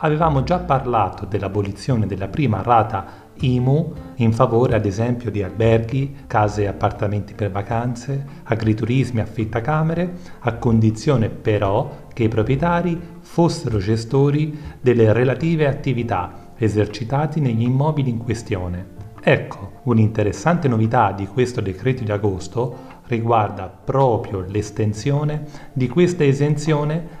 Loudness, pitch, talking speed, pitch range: -20 LUFS, 115 Hz, 115 wpm, 105-140 Hz